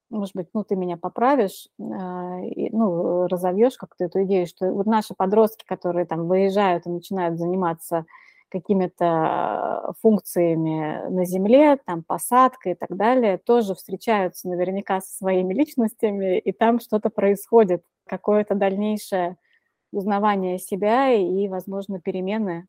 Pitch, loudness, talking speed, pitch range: 195 Hz, -22 LUFS, 125 wpm, 180-215 Hz